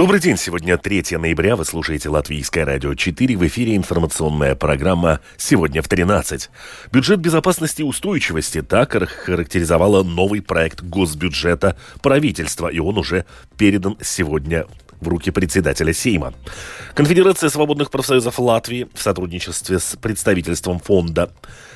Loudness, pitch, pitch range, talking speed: -18 LUFS, 90 Hz, 80-105 Hz, 125 wpm